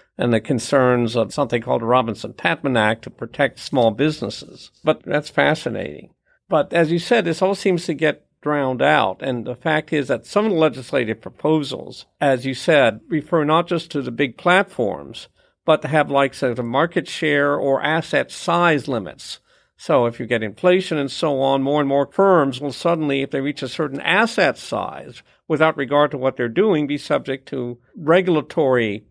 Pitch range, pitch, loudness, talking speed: 130-160 Hz, 145 Hz, -19 LUFS, 190 wpm